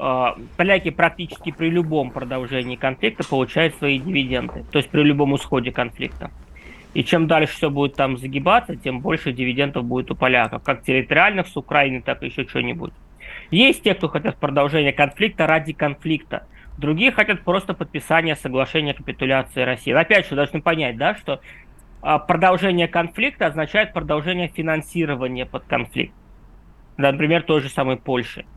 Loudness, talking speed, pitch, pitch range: -20 LUFS, 150 wpm, 150 Hz, 135-170 Hz